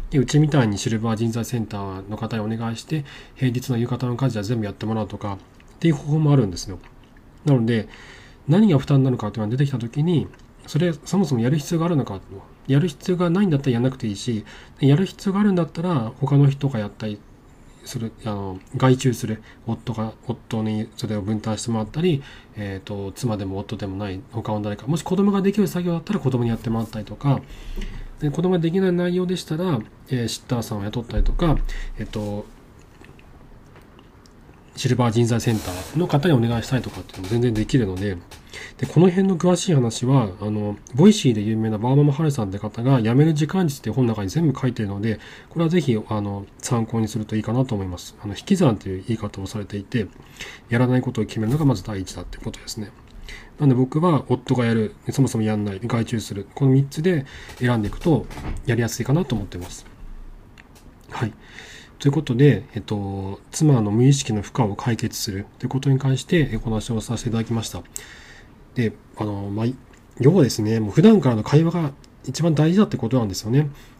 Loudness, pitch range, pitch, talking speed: -22 LUFS, 110-140 Hz, 120 Hz, 415 characters per minute